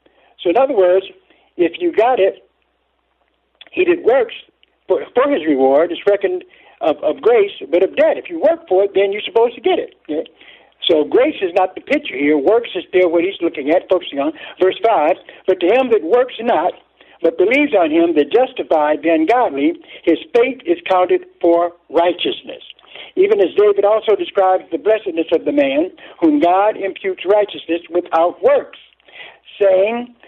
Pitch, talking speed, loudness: 210 Hz, 180 wpm, -16 LUFS